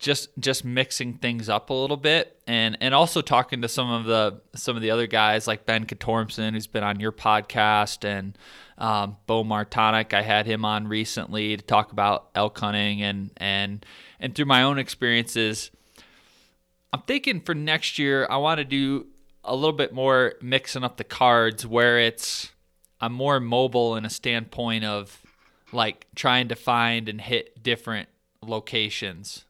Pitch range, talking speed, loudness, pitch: 105-125 Hz, 170 wpm, -24 LUFS, 115 Hz